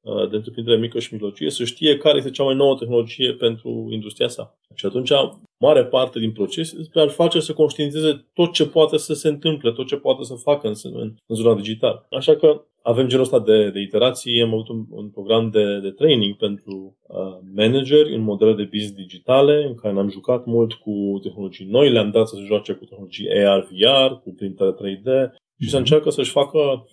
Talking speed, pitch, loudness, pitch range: 205 wpm, 115 Hz, -19 LUFS, 105-140 Hz